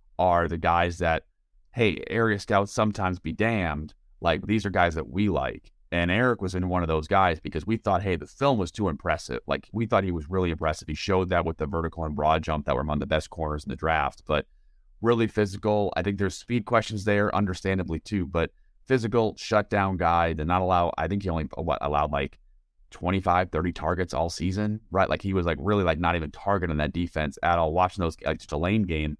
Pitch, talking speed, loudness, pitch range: 90 Hz, 225 wpm, -26 LUFS, 80-100 Hz